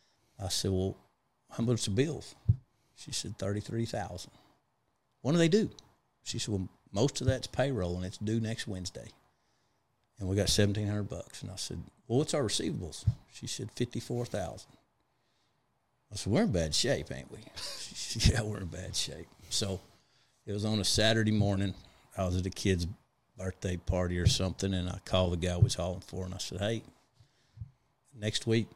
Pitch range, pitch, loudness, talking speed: 95-120 Hz, 105 Hz, -33 LUFS, 185 wpm